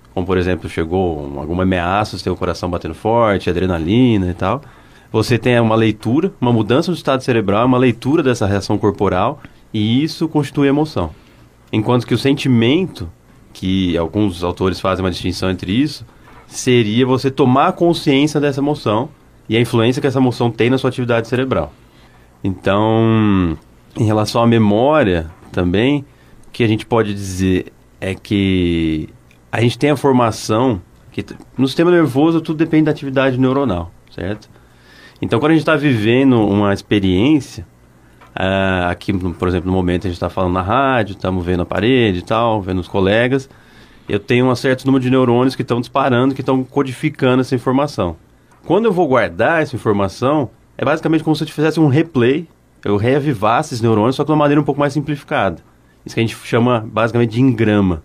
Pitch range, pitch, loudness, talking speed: 95-135 Hz, 115 Hz, -16 LUFS, 175 wpm